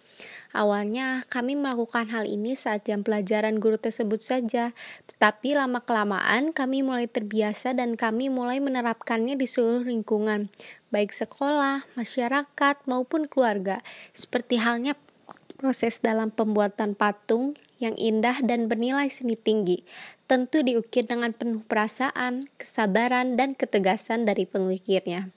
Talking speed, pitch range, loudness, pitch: 120 wpm, 215-255 Hz, -26 LUFS, 235 Hz